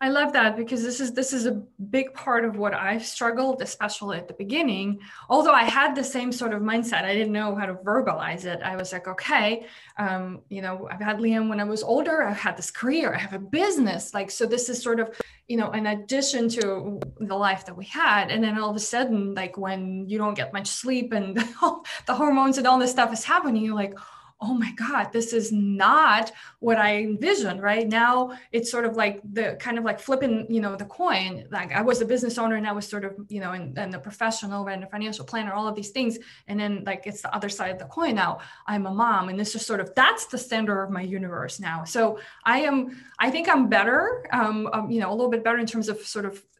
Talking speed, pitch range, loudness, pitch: 245 wpm, 200-240 Hz, -25 LUFS, 220 Hz